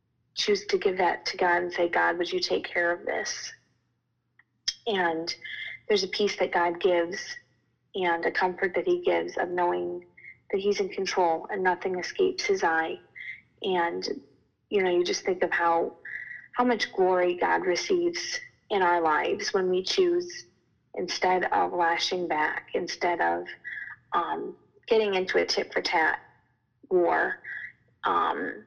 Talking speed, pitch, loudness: 155 wpm, 185 Hz, -27 LUFS